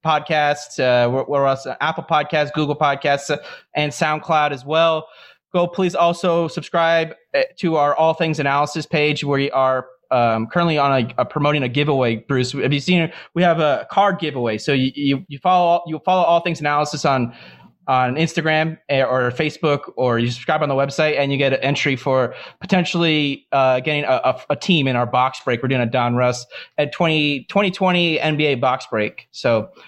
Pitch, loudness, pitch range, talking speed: 150 Hz, -19 LUFS, 130-165 Hz, 185 wpm